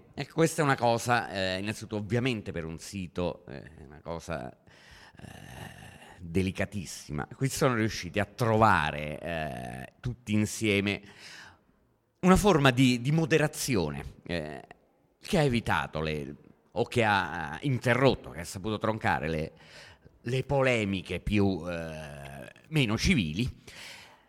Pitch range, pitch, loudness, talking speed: 80-125 Hz, 105 Hz, -29 LUFS, 125 wpm